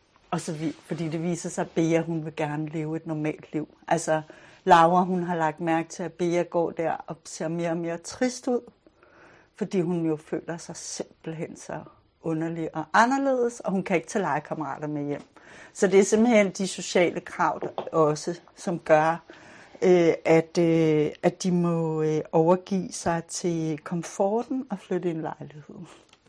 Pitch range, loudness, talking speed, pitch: 160-180 Hz, -26 LUFS, 180 wpm, 170 Hz